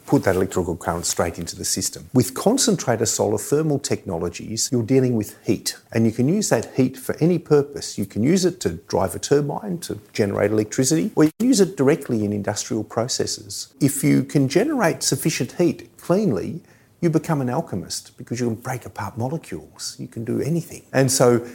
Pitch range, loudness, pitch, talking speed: 105-145 Hz, -21 LUFS, 125 Hz, 190 wpm